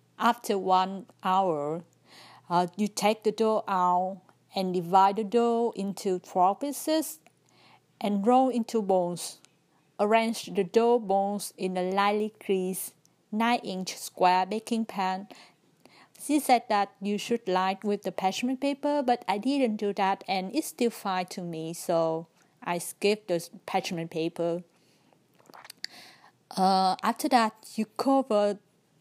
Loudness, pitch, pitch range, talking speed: -28 LUFS, 200 Hz, 185-225 Hz, 135 wpm